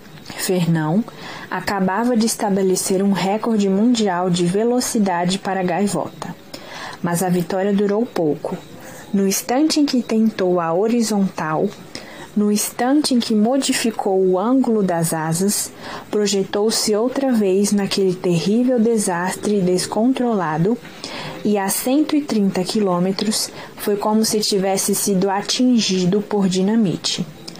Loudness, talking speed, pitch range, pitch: -18 LUFS, 110 wpm, 185-225 Hz, 200 Hz